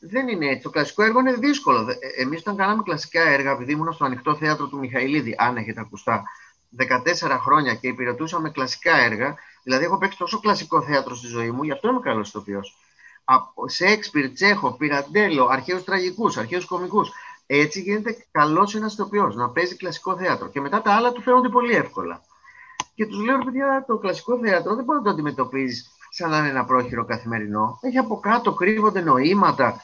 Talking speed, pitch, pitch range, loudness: 185 wpm, 175 Hz, 135-215 Hz, -21 LUFS